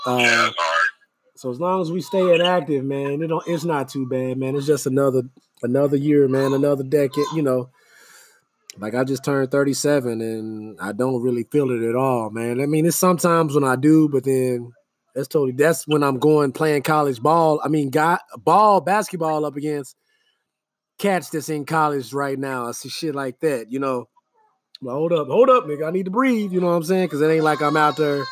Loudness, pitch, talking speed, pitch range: -20 LUFS, 145 Hz, 215 wpm, 135-165 Hz